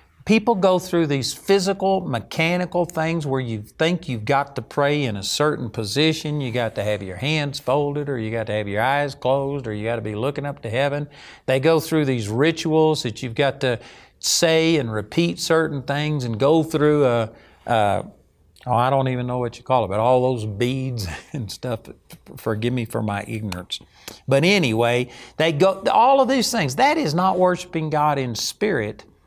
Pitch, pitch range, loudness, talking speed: 140 Hz, 120-160 Hz, -21 LUFS, 195 wpm